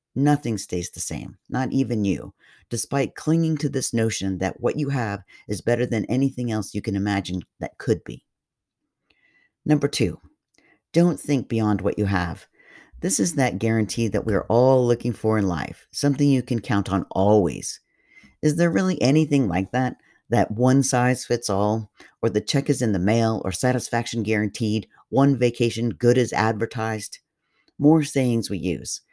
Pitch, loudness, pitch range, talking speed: 115 Hz, -23 LUFS, 105-130 Hz, 170 wpm